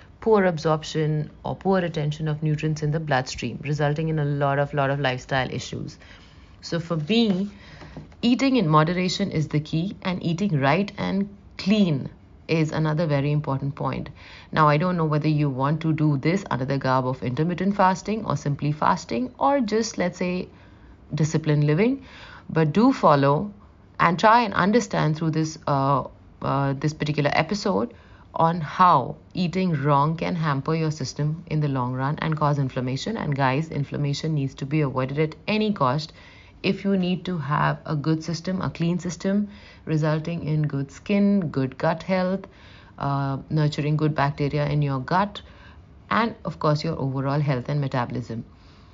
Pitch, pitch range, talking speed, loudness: 155 Hz, 140-180 Hz, 165 wpm, -24 LUFS